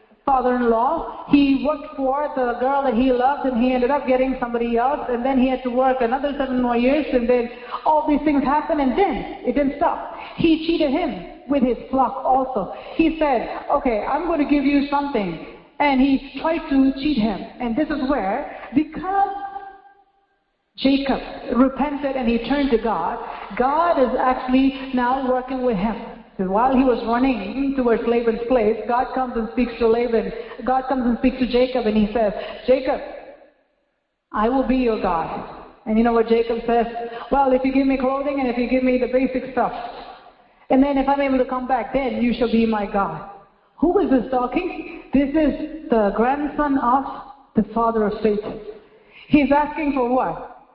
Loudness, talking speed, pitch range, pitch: -20 LUFS, 190 wpm, 235-285 Hz, 260 Hz